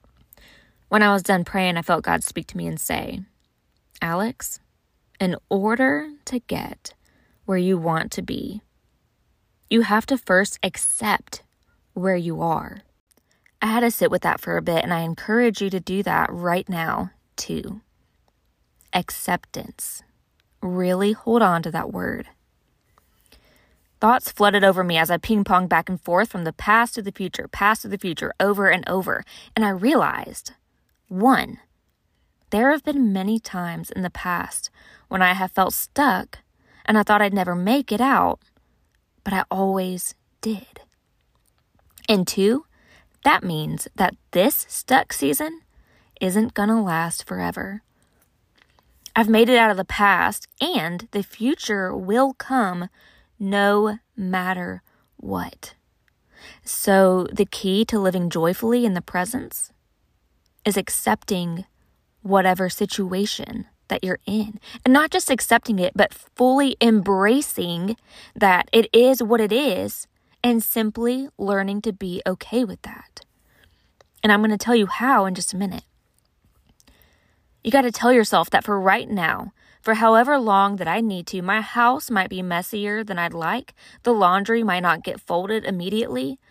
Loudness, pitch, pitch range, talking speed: -21 LUFS, 200 Hz, 185-230 Hz, 150 wpm